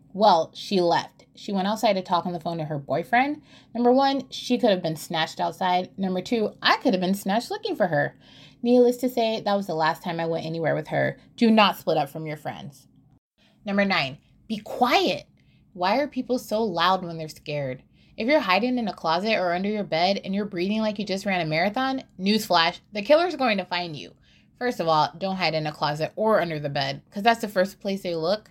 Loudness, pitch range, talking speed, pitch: -24 LUFS, 165-225 Hz, 230 wpm, 190 Hz